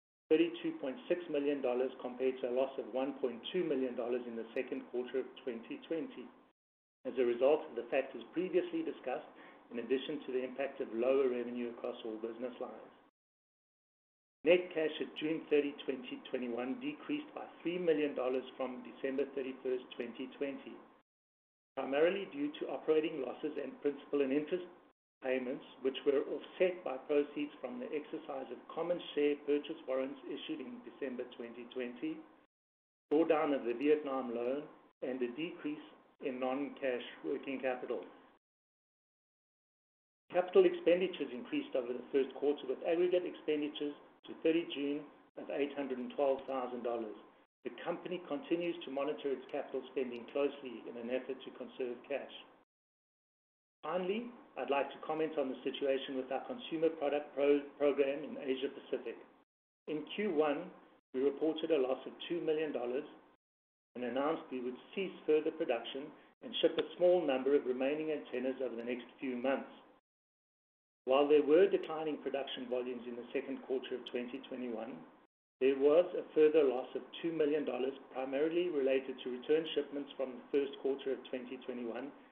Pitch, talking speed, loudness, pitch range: 140 Hz, 145 wpm, -37 LUFS, 130-160 Hz